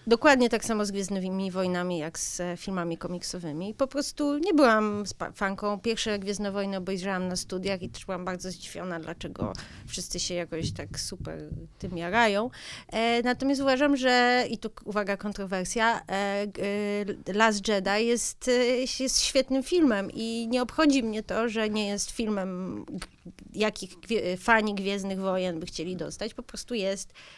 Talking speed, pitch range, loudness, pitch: 150 wpm, 185-230 Hz, -28 LUFS, 205 Hz